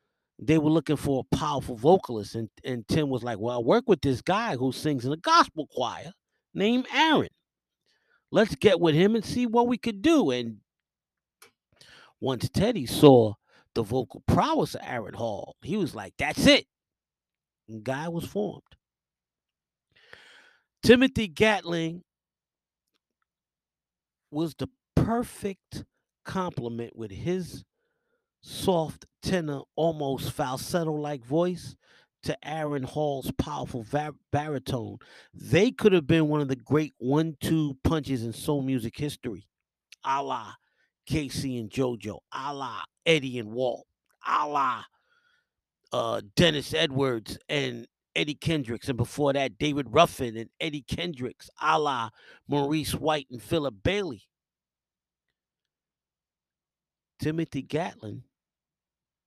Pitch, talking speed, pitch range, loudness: 145 Hz, 125 wpm, 125-165 Hz, -27 LUFS